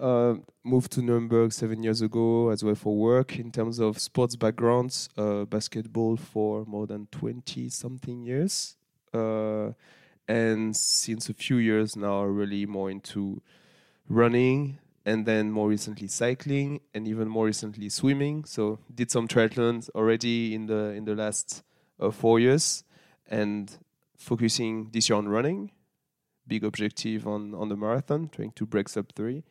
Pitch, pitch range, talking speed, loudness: 110 Hz, 105-120 Hz, 155 wpm, -27 LUFS